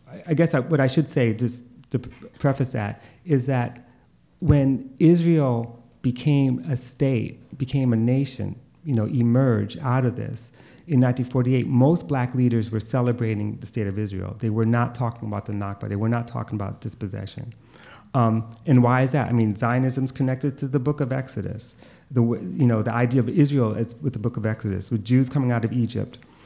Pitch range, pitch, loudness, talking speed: 115-135 Hz, 125 Hz, -23 LUFS, 190 wpm